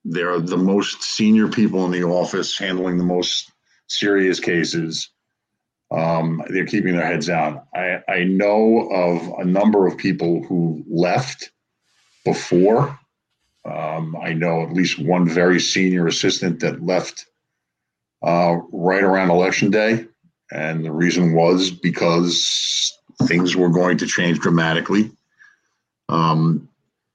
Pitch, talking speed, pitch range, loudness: 90 Hz, 130 wpm, 85-95 Hz, -19 LUFS